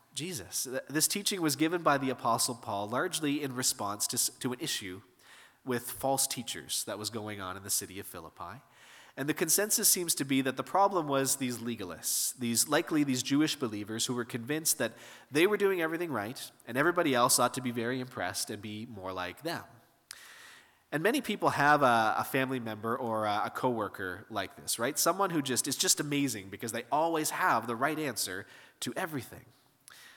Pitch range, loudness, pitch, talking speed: 115-155 Hz, -30 LUFS, 130 Hz, 195 wpm